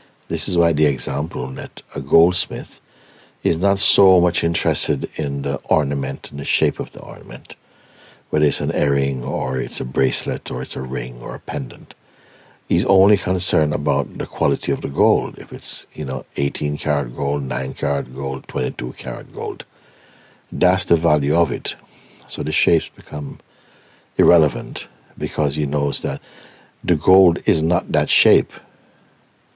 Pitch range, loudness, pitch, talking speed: 70-85 Hz, -19 LUFS, 75 Hz, 160 wpm